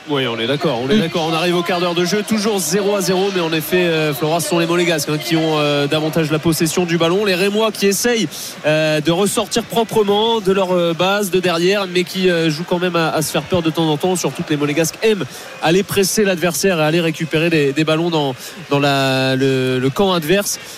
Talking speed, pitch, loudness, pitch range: 245 wpm, 170 Hz, -16 LUFS, 155-195 Hz